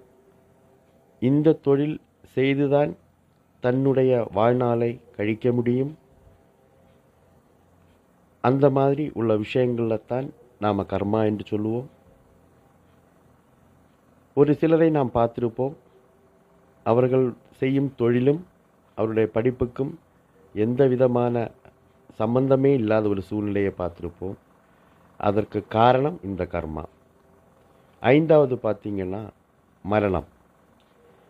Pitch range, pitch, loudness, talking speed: 105-130 Hz, 120 Hz, -23 LUFS, 75 wpm